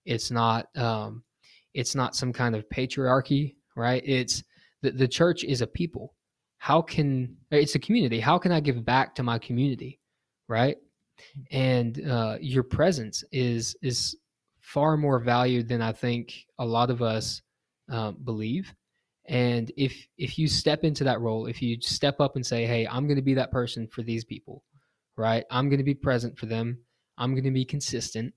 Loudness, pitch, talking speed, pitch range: -27 LUFS, 125 Hz, 180 wpm, 115-140 Hz